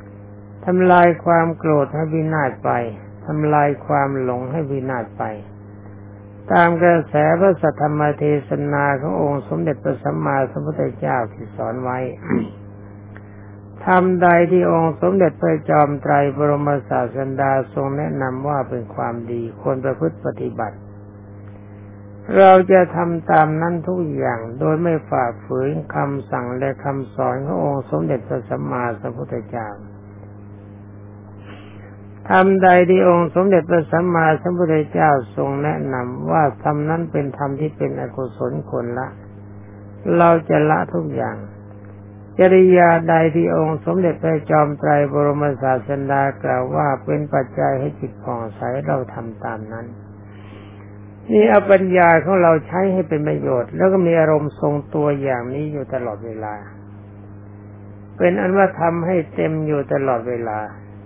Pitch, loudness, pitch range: 135 Hz, -18 LUFS, 105-160 Hz